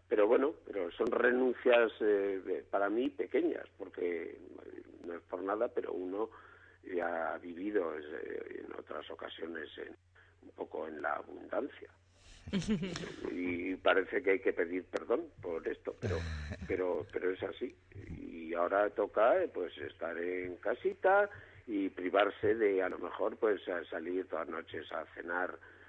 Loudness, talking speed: -35 LUFS, 155 wpm